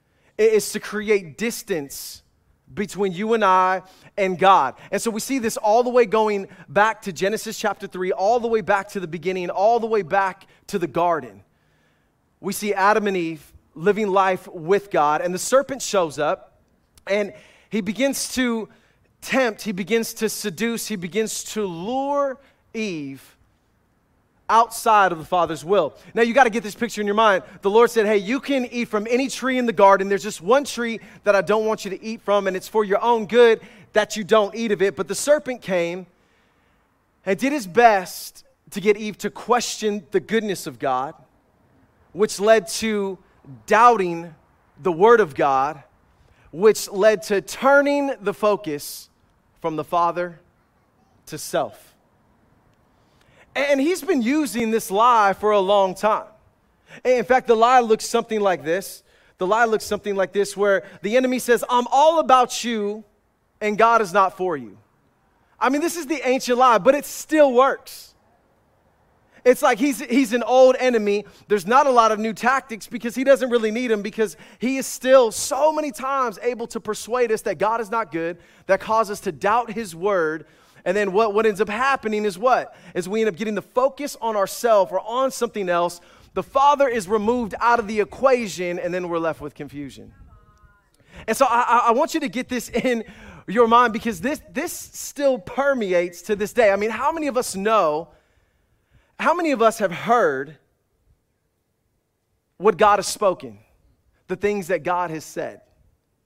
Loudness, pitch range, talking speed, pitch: -20 LUFS, 185-240 Hz, 185 wpm, 215 Hz